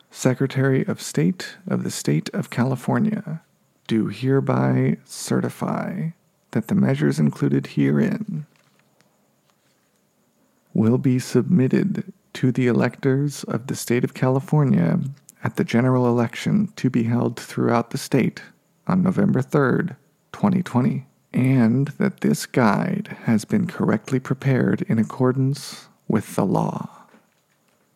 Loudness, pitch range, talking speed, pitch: -22 LUFS, 125-190 Hz, 115 wpm, 135 Hz